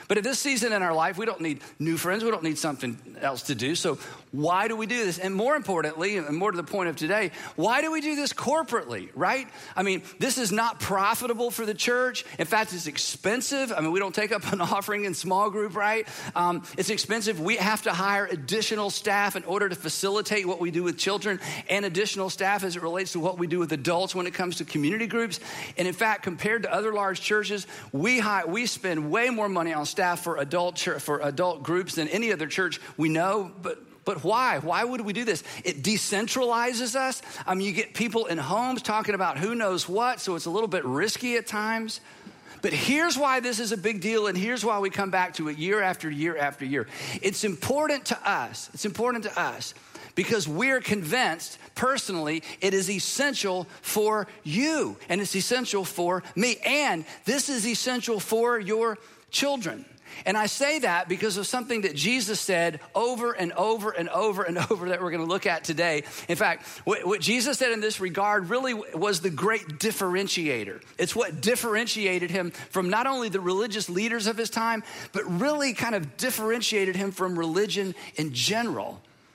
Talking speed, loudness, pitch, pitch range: 210 wpm, -27 LUFS, 200 Hz, 175-225 Hz